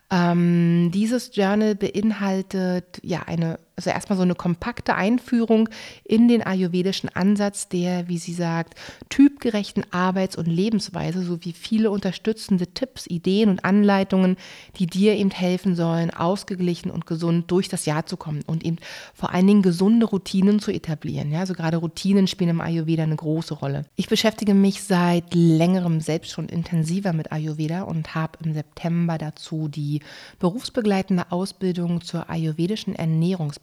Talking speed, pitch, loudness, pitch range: 150 wpm, 180 Hz, -22 LUFS, 165-195 Hz